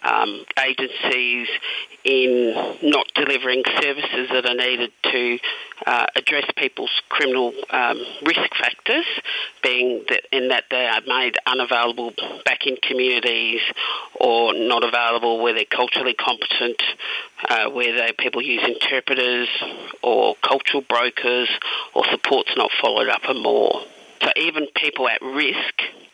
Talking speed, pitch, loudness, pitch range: 130 wpm, 125 Hz, -19 LUFS, 120-130 Hz